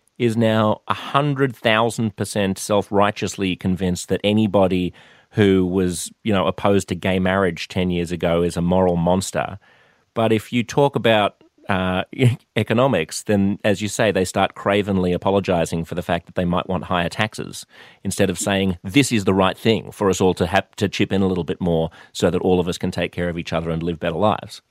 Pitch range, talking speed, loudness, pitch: 90-105 Hz, 205 wpm, -20 LUFS, 95 Hz